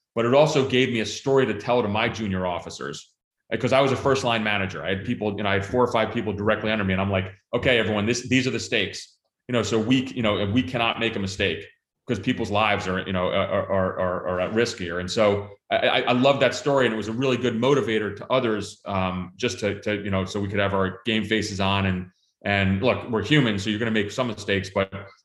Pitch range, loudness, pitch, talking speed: 100-120 Hz, -23 LUFS, 110 Hz, 265 wpm